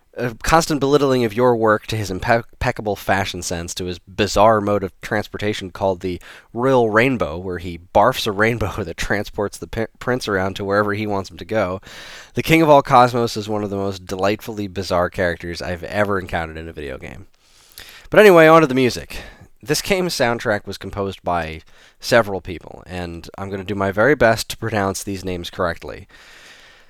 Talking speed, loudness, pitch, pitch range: 190 wpm, -18 LUFS, 100 Hz, 95-115 Hz